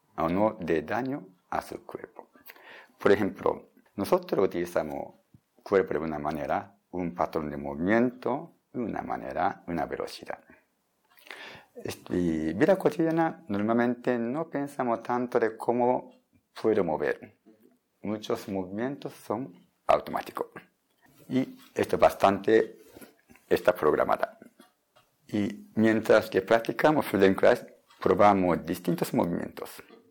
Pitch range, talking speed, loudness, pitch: 95-140 Hz, 110 wpm, -28 LUFS, 115 Hz